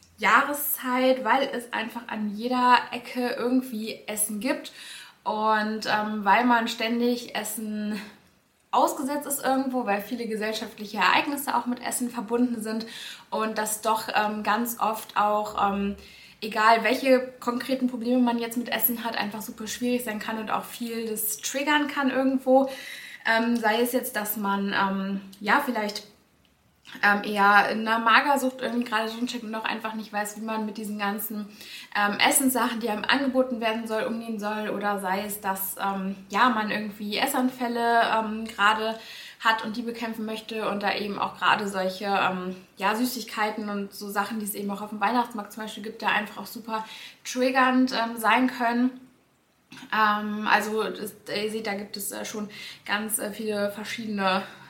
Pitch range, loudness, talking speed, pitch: 210-245 Hz, -26 LUFS, 165 wpm, 220 Hz